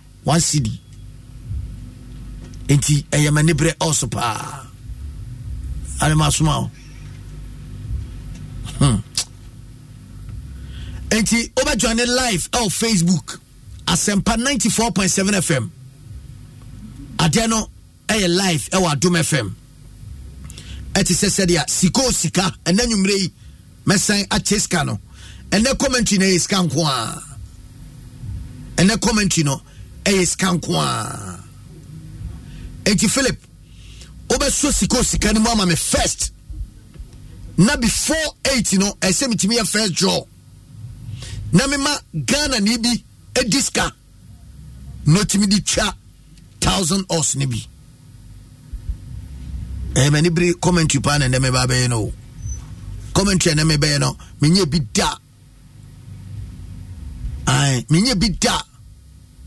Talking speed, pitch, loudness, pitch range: 100 wpm, 145 Hz, -17 LUFS, 115-190 Hz